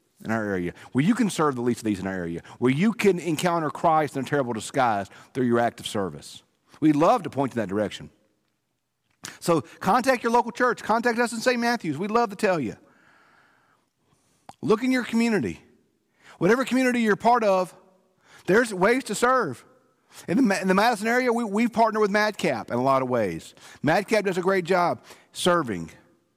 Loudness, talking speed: -24 LUFS, 185 wpm